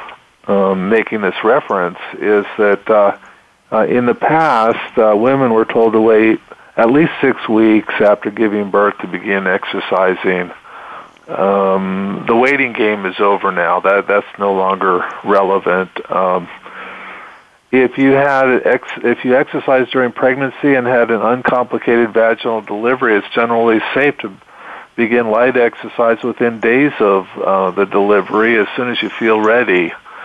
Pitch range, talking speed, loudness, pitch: 100-120 Hz, 145 wpm, -13 LUFS, 110 Hz